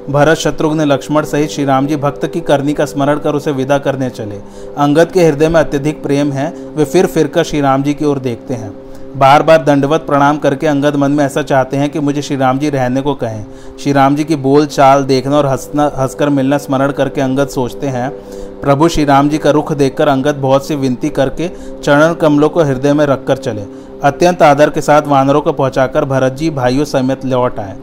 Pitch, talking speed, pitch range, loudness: 140 Hz, 220 wpm, 135-150 Hz, -12 LUFS